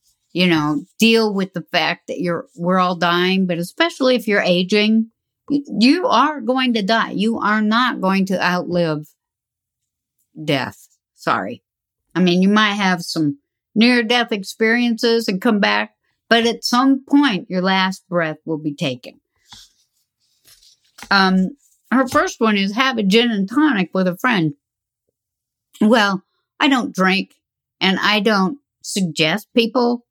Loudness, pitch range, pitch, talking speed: -17 LUFS, 175-230 Hz, 195 Hz, 145 wpm